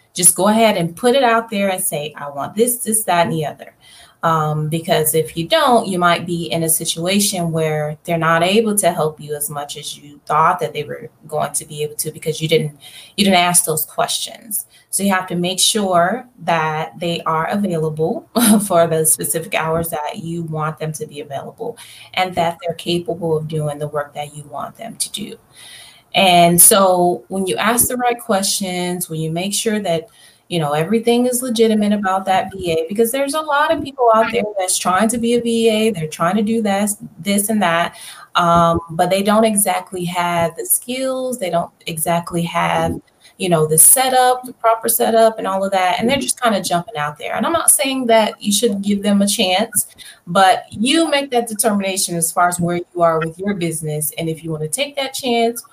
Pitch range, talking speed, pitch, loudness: 165-225 Hz, 215 wpm, 180 Hz, -16 LUFS